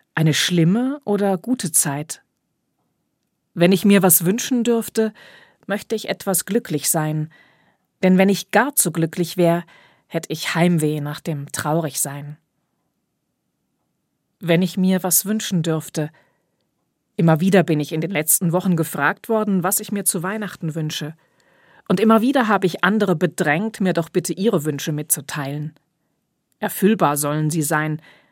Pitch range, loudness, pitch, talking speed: 155-200 Hz, -19 LUFS, 175 Hz, 145 wpm